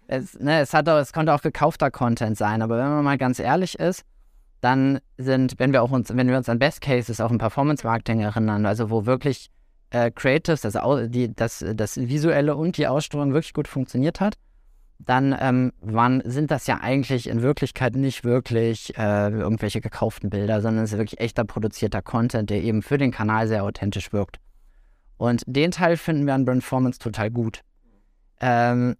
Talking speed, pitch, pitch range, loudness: 190 wpm, 120 Hz, 110-135 Hz, -23 LUFS